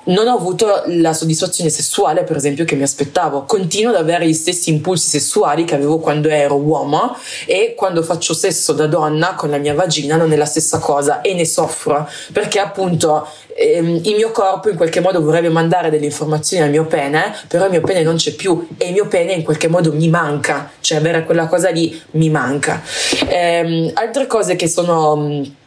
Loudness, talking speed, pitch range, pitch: -15 LUFS, 200 wpm, 155-180 Hz, 165 Hz